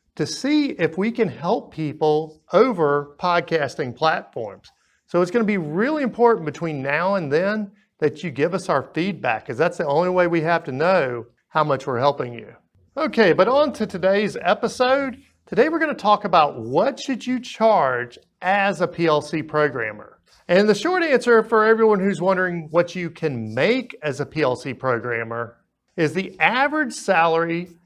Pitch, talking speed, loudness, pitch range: 180 Hz, 175 wpm, -21 LUFS, 155-225 Hz